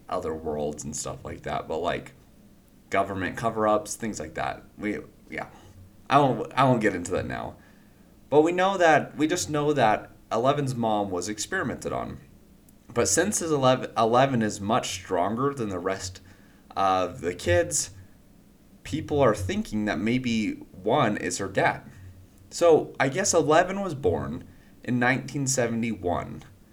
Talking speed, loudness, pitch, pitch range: 150 wpm, -25 LUFS, 110 Hz, 95-135 Hz